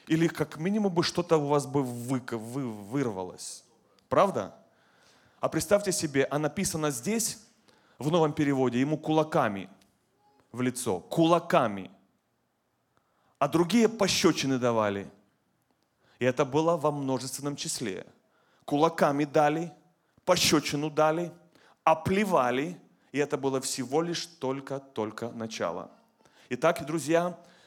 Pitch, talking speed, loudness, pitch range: 150 Hz, 105 wpm, -28 LUFS, 130-165 Hz